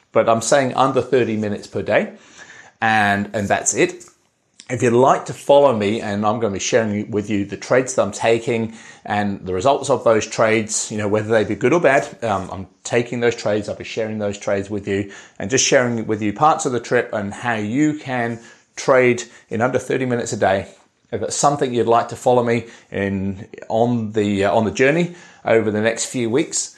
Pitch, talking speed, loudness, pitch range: 110 Hz, 215 wpm, -19 LUFS, 105-120 Hz